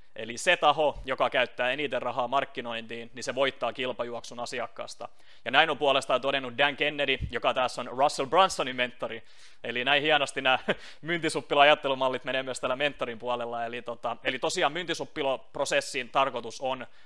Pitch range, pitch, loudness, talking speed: 120-140 Hz, 130 Hz, -27 LUFS, 150 wpm